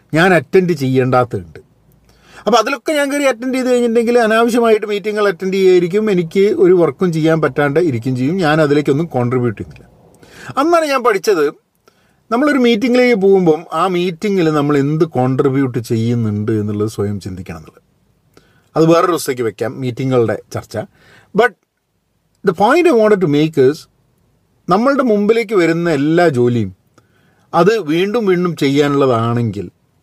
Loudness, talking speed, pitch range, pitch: -14 LUFS, 125 wpm, 130-215 Hz, 165 Hz